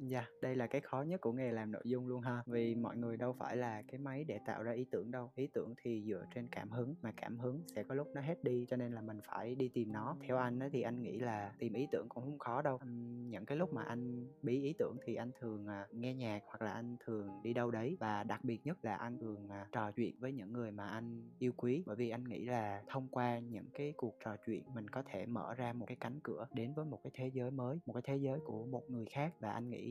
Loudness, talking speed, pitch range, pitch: -43 LUFS, 285 wpm, 115-130 Hz, 120 Hz